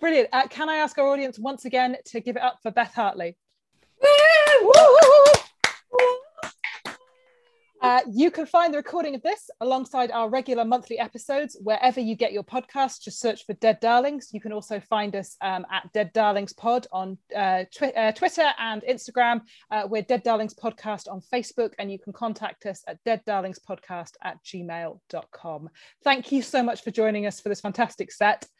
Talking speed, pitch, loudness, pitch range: 175 wpm, 235 Hz, -22 LUFS, 210-270 Hz